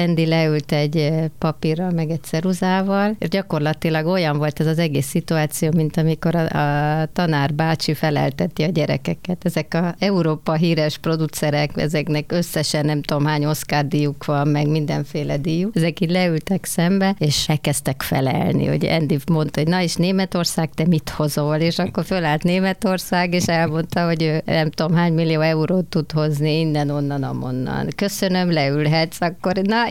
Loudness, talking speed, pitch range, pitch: -20 LUFS, 160 wpm, 150-175 Hz, 160 Hz